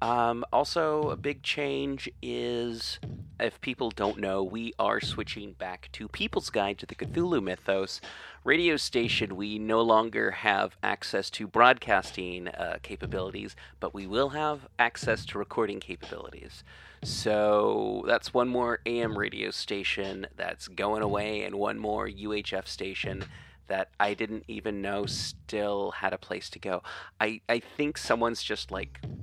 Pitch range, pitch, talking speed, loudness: 100-120 Hz, 110 Hz, 150 wpm, -30 LUFS